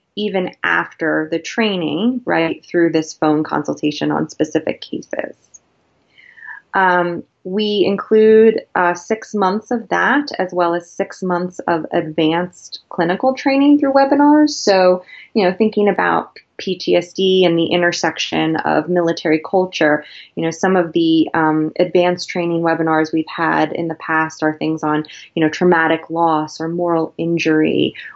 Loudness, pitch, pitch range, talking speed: -16 LUFS, 175 Hz, 160-200 Hz, 145 wpm